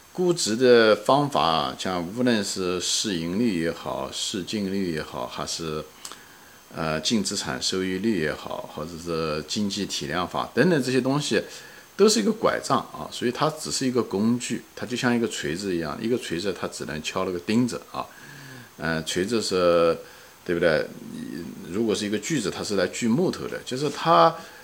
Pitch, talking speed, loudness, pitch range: 105 Hz, 260 characters per minute, -24 LUFS, 85-125 Hz